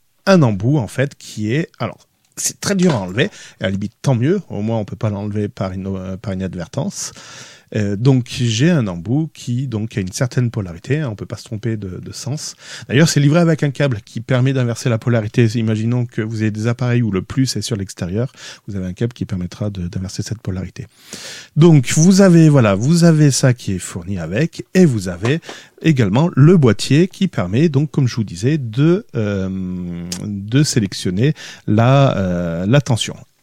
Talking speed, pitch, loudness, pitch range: 200 wpm, 120 Hz, -17 LUFS, 100-145 Hz